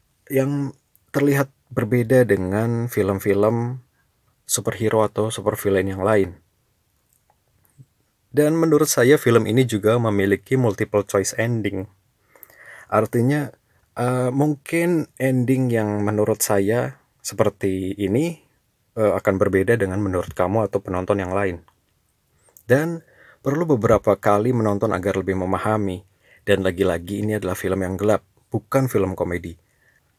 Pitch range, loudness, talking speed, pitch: 95-125 Hz, -21 LUFS, 115 wpm, 105 Hz